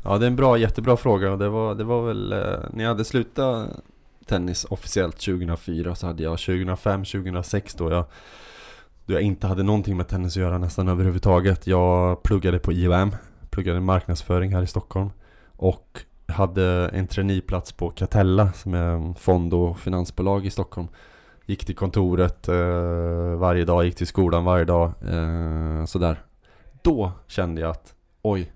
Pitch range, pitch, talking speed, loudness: 85-100 Hz, 90 Hz, 165 wpm, -23 LUFS